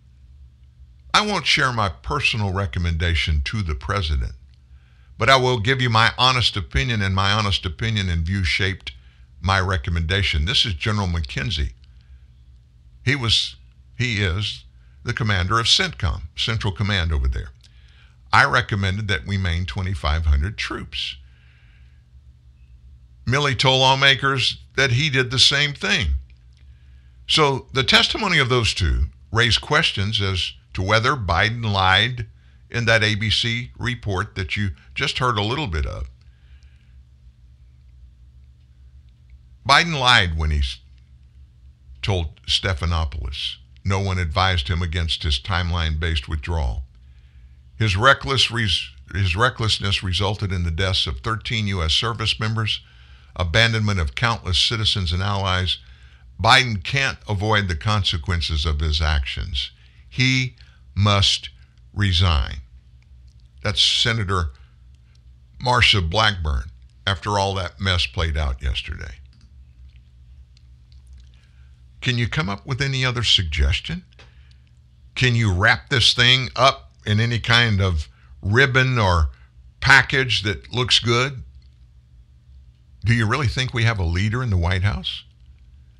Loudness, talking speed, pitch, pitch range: -20 LUFS, 125 wpm, 85 Hz, 65-105 Hz